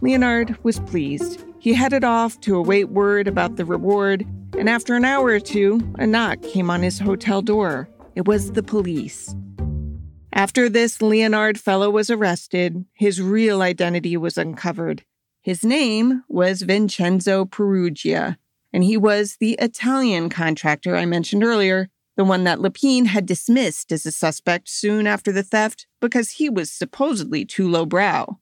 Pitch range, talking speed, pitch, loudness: 180-230 Hz, 155 wpm, 200 Hz, -20 LUFS